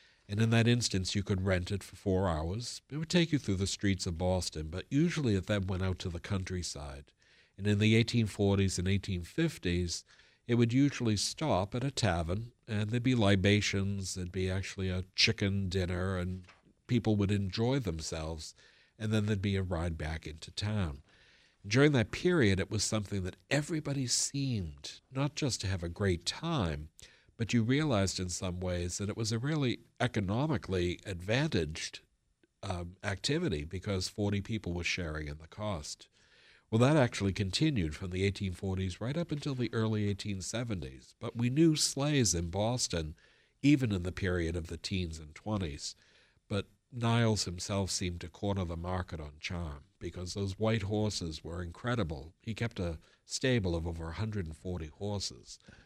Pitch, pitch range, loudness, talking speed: 100 Hz, 90-115 Hz, -33 LUFS, 170 wpm